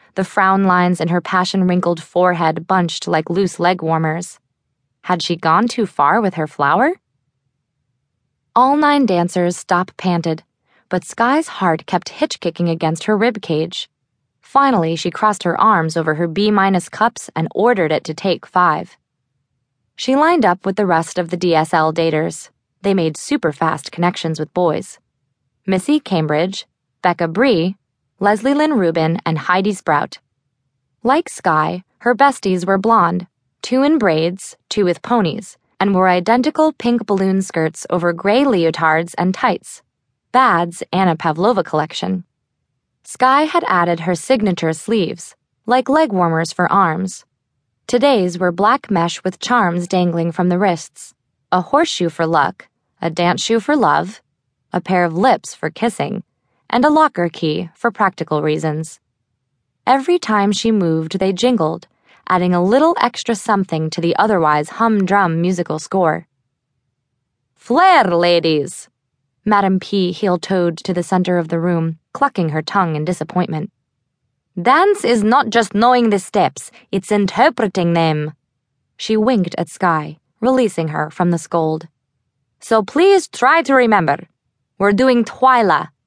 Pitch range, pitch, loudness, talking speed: 160-215 Hz, 180 Hz, -16 LUFS, 140 wpm